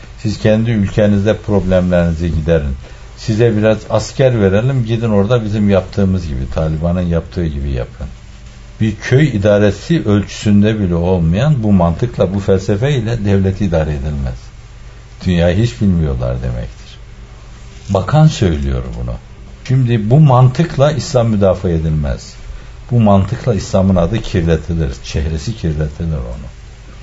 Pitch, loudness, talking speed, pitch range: 100 Hz, -14 LUFS, 120 wpm, 80-115 Hz